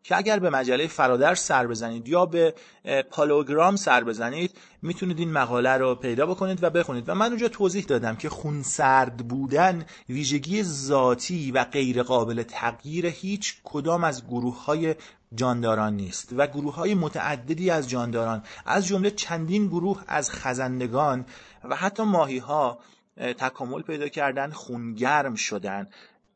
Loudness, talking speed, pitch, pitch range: -25 LUFS, 145 wpm, 145 Hz, 125-175 Hz